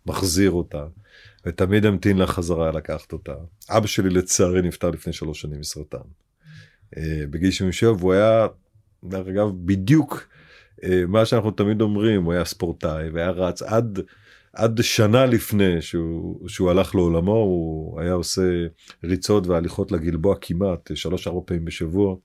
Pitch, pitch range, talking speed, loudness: 95 Hz, 85-105 Hz, 140 wpm, -21 LUFS